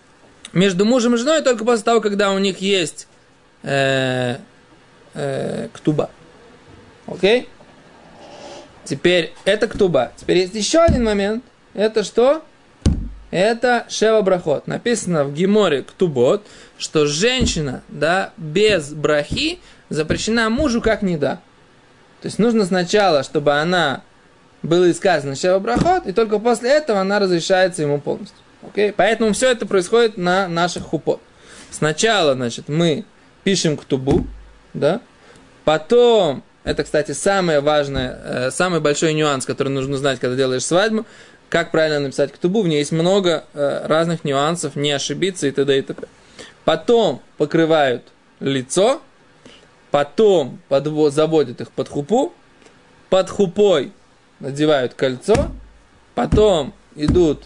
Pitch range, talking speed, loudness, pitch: 150-215 Hz, 125 wpm, -18 LUFS, 180 Hz